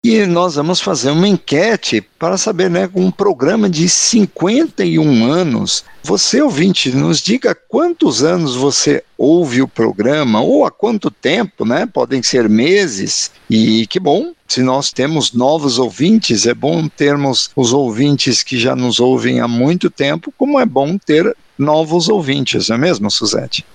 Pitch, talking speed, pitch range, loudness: 150 Hz, 160 wpm, 130-185 Hz, -13 LUFS